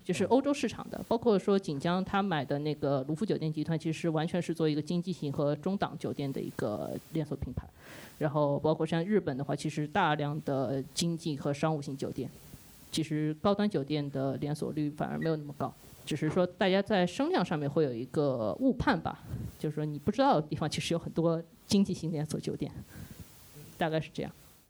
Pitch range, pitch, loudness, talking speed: 150-180 Hz, 155 Hz, -32 LUFS, 315 characters per minute